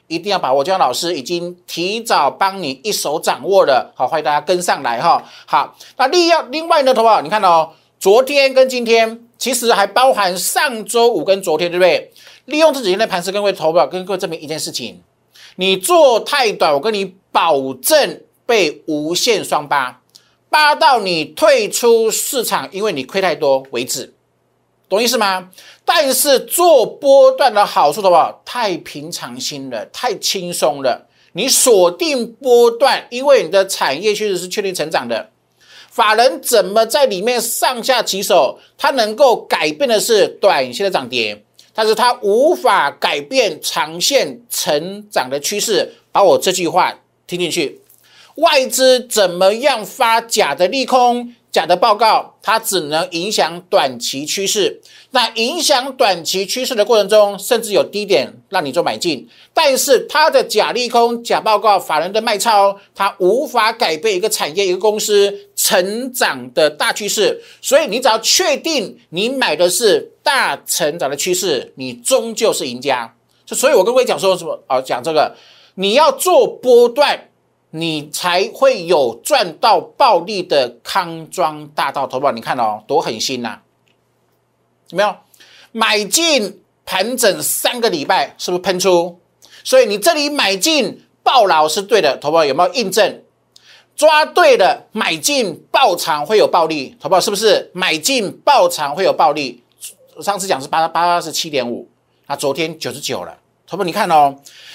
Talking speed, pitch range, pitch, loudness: 240 characters per minute, 180-290 Hz, 215 Hz, -15 LUFS